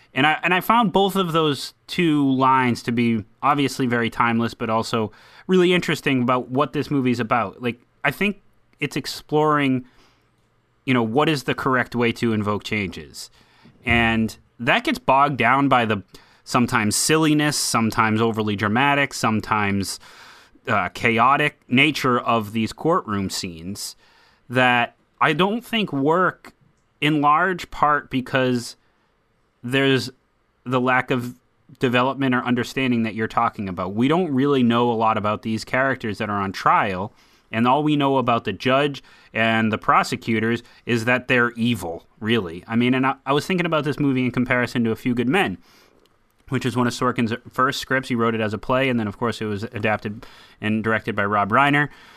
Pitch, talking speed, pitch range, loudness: 125 Hz, 170 wpm, 115-140 Hz, -21 LUFS